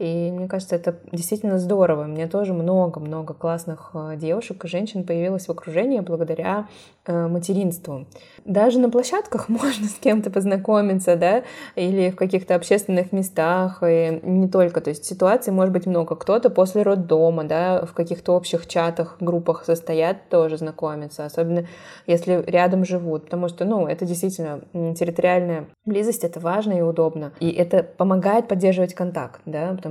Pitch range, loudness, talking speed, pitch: 165-190 Hz, -21 LUFS, 150 wpm, 175 Hz